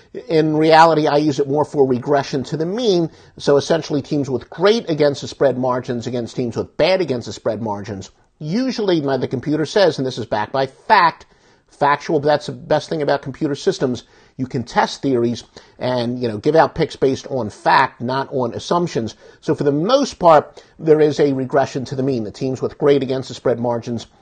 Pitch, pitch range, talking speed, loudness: 140 Hz, 125-155 Hz, 205 wpm, -18 LUFS